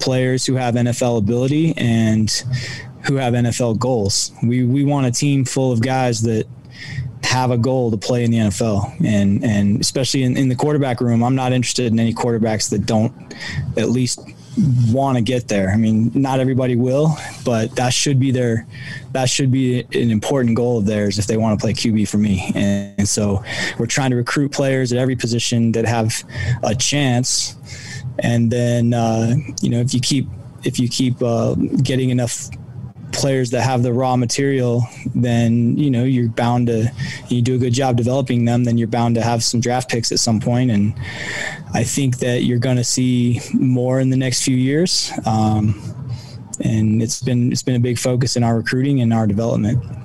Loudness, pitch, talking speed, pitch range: -18 LUFS, 120 Hz, 195 wpm, 115-130 Hz